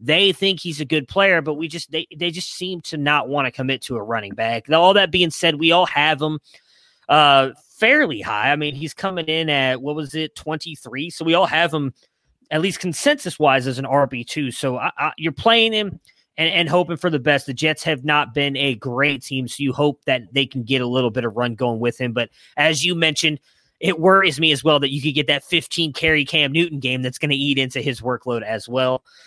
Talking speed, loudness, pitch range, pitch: 240 wpm, -19 LUFS, 135-165 Hz, 150 Hz